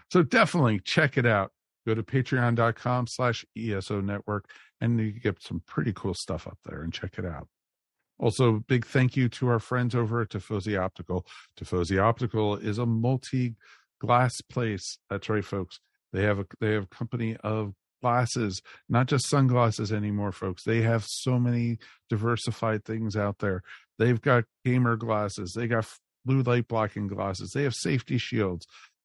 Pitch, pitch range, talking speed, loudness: 115 Hz, 105-125 Hz, 165 wpm, -28 LUFS